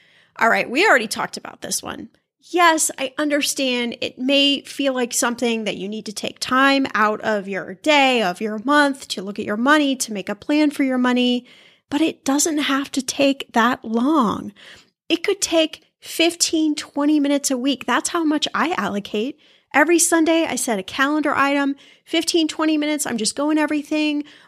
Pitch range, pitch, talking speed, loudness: 245-300 Hz, 280 Hz, 185 wpm, -19 LUFS